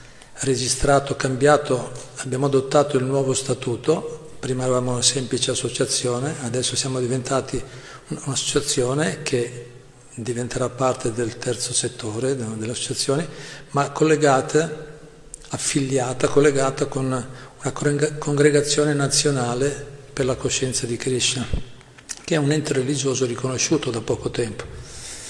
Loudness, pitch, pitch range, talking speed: -22 LUFS, 135 Hz, 125-145 Hz, 105 wpm